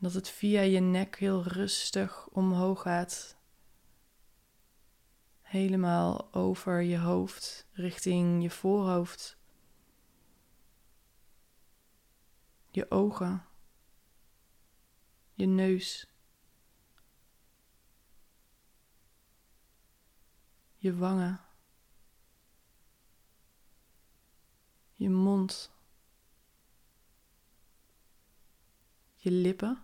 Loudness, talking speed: -31 LUFS, 50 wpm